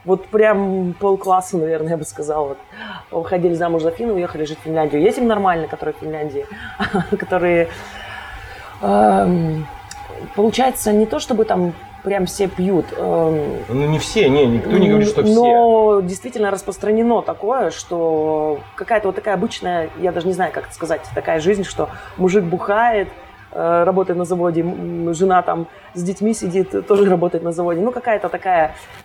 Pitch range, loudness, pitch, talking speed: 165-205 Hz, -18 LUFS, 185 Hz, 155 wpm